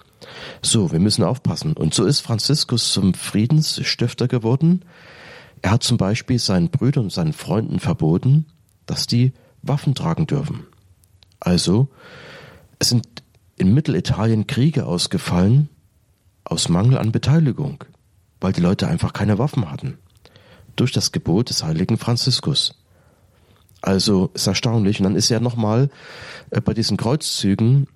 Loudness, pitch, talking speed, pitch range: -19 LUFS, 120 Hz, 135 wpm, 105-140 Hz